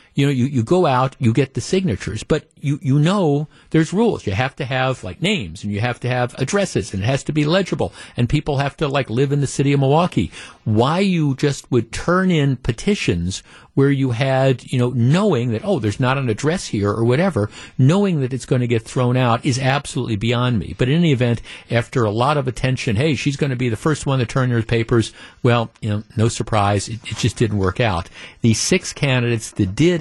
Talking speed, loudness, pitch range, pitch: 230 wpm, -19 LUFS, 115-145 Hz, 130 Hz